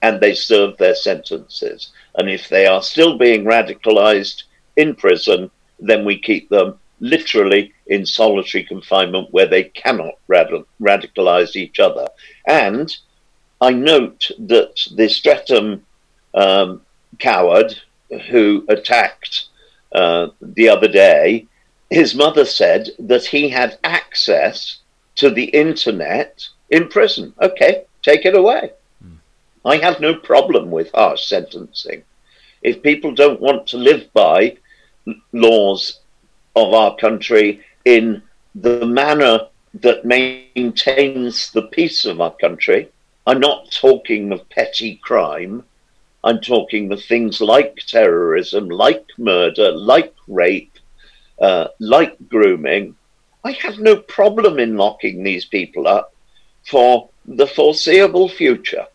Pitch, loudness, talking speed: 140 Hz, -14 LUFS, 120 wpm